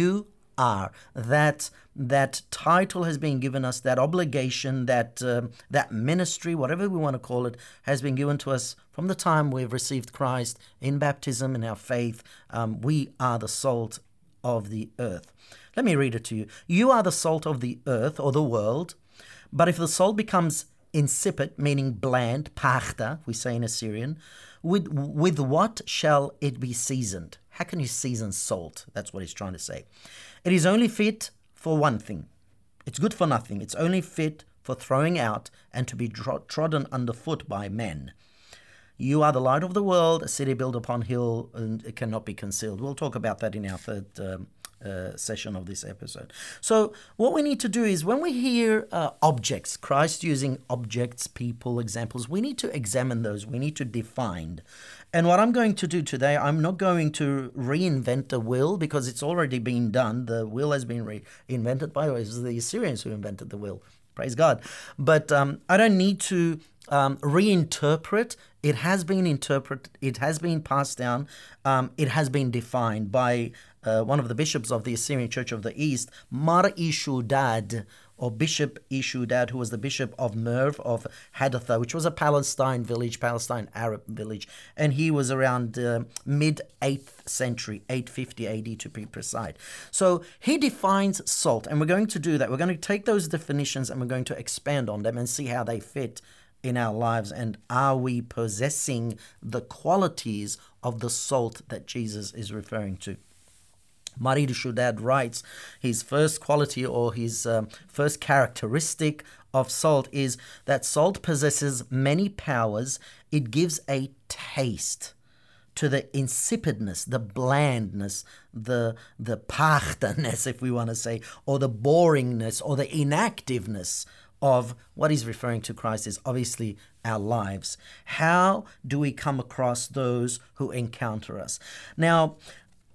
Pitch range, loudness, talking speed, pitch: 115-150 Hz, -26 LUFS, 175 wpm, 130 Hz